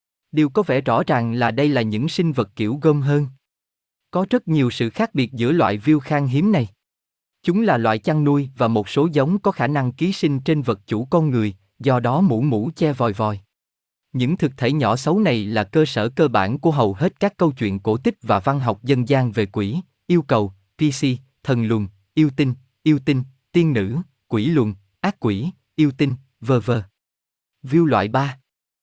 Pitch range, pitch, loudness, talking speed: 110-155 Hz, 130 Hz, -20 LUFS, 205 wpm